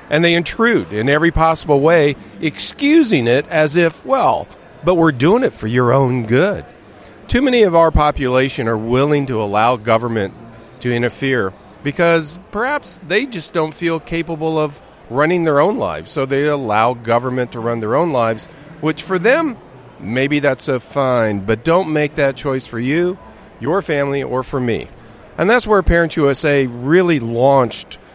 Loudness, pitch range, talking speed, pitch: -16 LUFS, 125-165 Hz, 170 wpm, 145 Hz